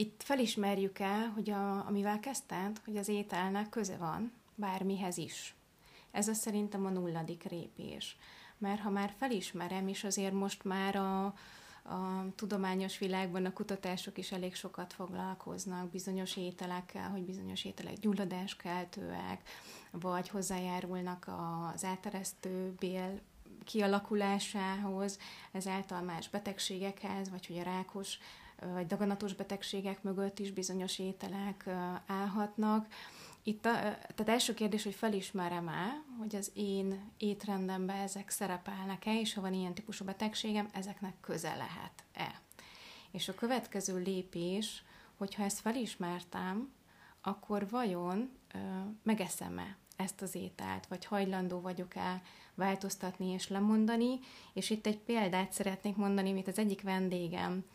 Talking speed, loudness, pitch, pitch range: 125 wpm, -38 LUFS, 195 Hz, 185-205 Hz